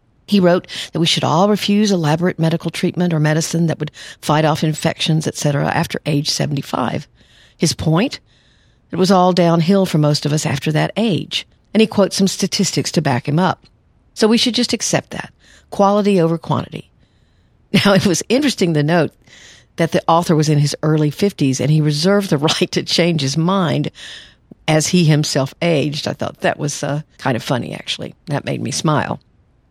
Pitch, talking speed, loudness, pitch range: 165 Hz, 185 wpm, -16 LUFS, 150-190 Hz